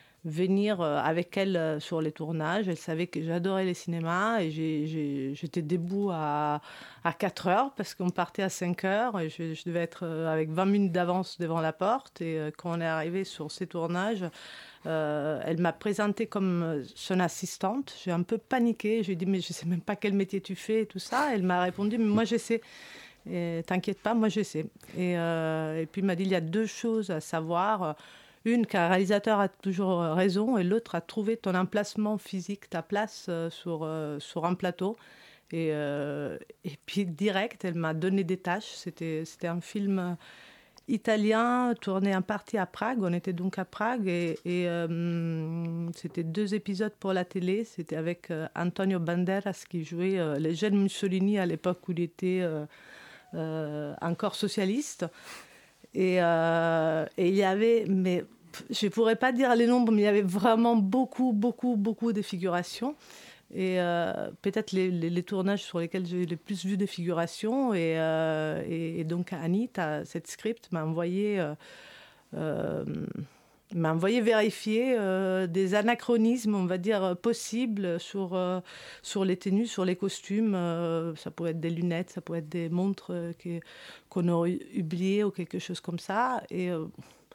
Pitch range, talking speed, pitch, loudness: 170-205 Hz, 185 wpm, 185 Hz, -30 LUFS